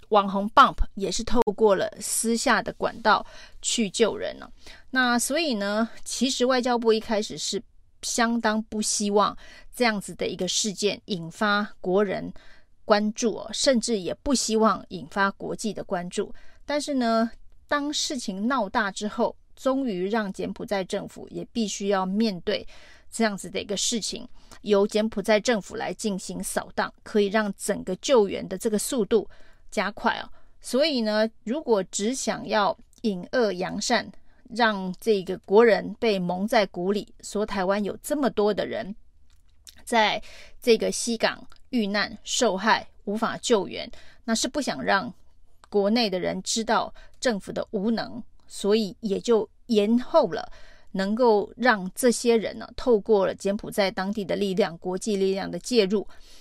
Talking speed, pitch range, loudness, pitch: 230 characters per minute, 195-230 Hz, -25 LUFS, 215 Hz